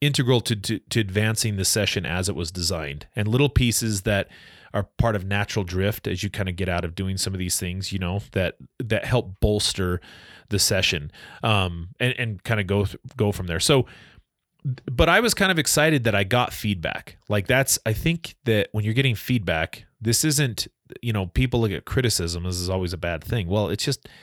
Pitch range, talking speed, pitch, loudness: 95-120 Hz, 215 wpm, 105 Hz, -23 LUFS